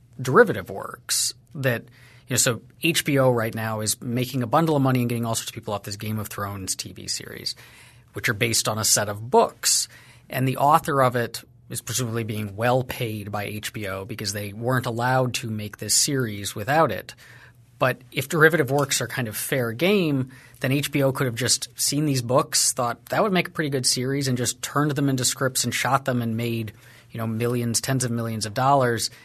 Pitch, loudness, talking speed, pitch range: 120 Hz, -23 LUFS, 210 wpm, 115-130 Hz